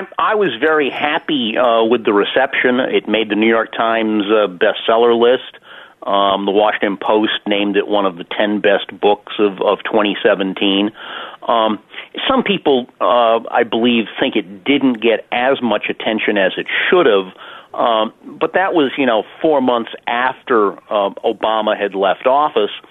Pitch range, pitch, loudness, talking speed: 100-115 Hz, 105 Hz, -15 LUFS, 165 wpm